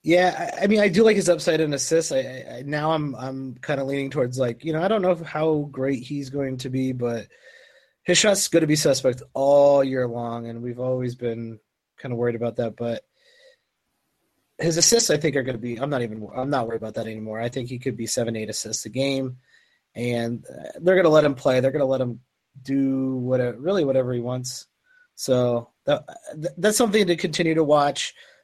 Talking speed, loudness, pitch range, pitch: 215 wpm, -23 LUFS, 120-160 Hz, 135 Hz